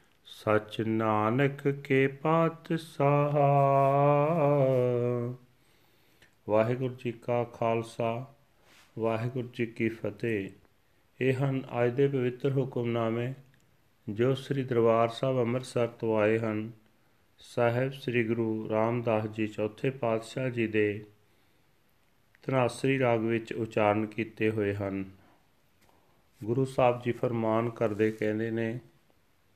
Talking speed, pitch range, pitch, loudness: 100 wpm, 110-130 Hz, 115 Hz, -29 LUFS